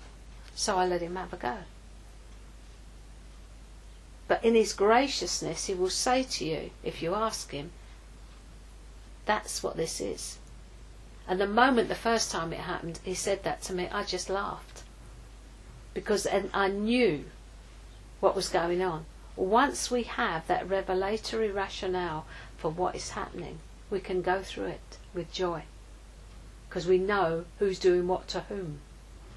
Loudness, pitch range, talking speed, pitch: -30 LUFS, 165-205 Hz, 145 wpm, 185 Hz